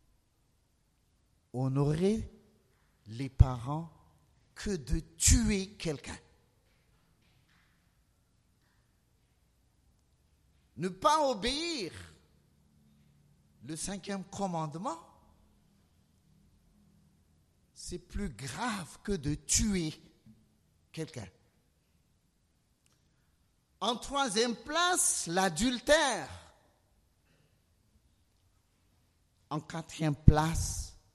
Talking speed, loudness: 50 wpm, -32 LUFS